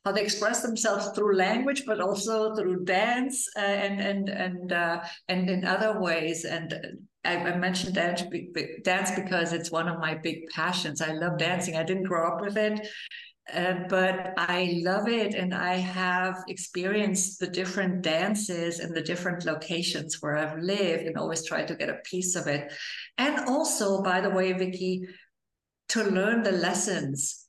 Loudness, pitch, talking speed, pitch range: -28 LUFS, 185 Hz, 165 wpm, 170-200 Hz